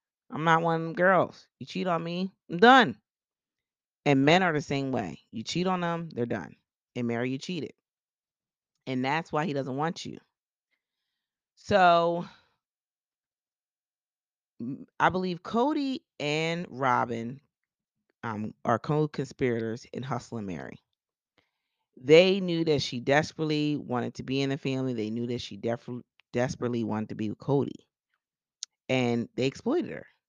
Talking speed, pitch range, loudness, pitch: 145 wpm, 120-165 Hz, -27 LUFS, 140 Hz